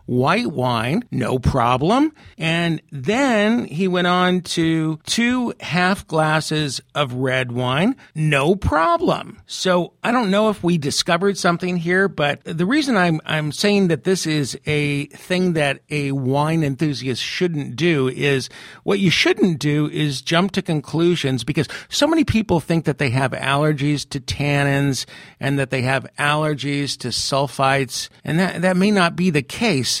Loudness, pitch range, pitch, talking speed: -19 LUFS, 140-180 Hz, 155 Hz, 160 wpm